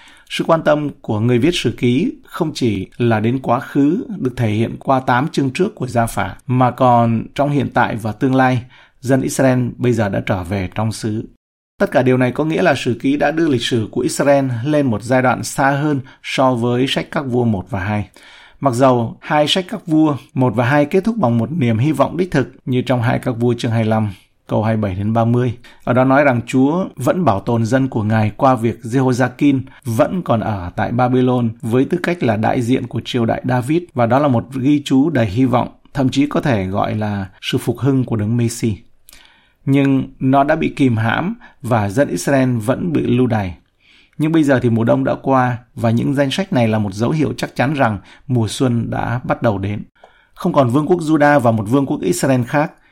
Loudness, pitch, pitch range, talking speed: -17 LUFS, 125 Hz, 115-140 Hz, 225 wpm